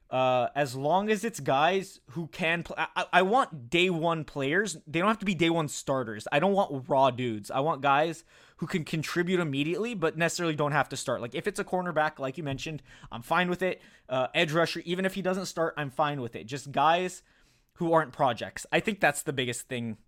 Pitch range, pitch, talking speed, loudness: 135-180 Hz, 160 Hz, 225 wpm, -28 LUFS